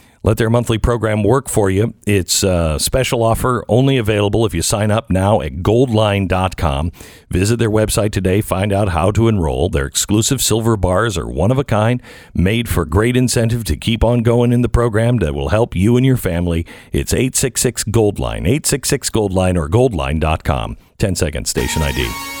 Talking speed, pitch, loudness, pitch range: 180 wpm, 105 Hz, -16 LUFS, 90-120 Hz